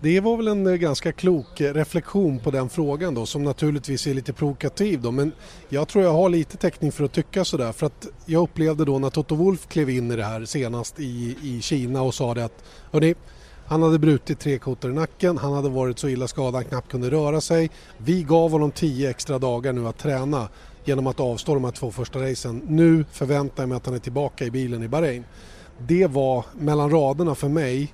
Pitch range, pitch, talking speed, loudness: 130-160 Hz, 145 Hz, 225 wpm, -23 LUFS